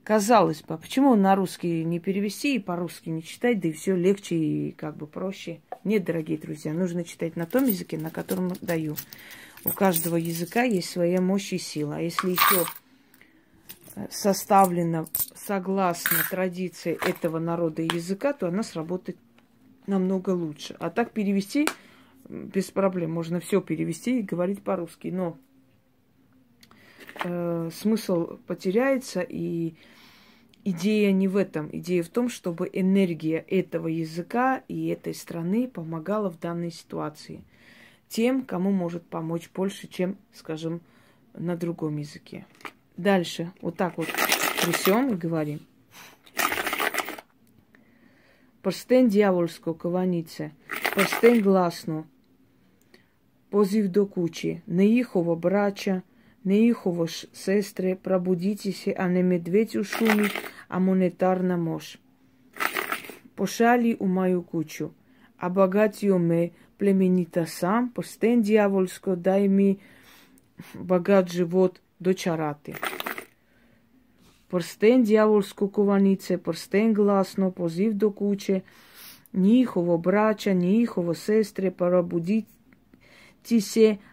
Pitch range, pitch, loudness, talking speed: 170-205 Hz, 185 Hz, -25 LUFS, 110 wpm